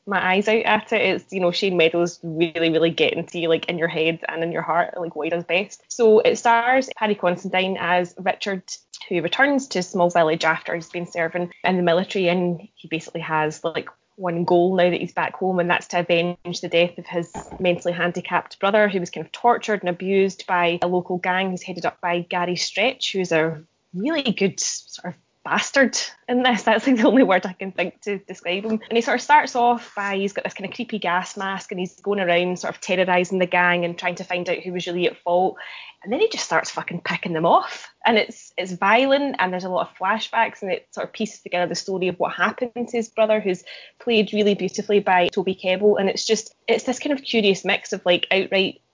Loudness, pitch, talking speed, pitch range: -21 LUFS, 185 Hz, 235 wpm, 175-215 Hz